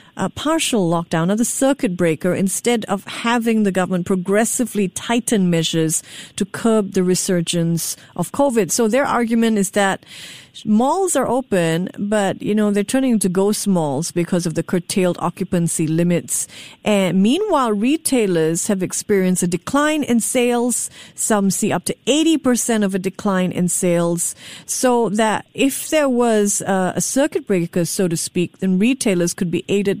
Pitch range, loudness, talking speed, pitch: 175-235 Hz, -18 LUFS, 160 wpm, 200 Hz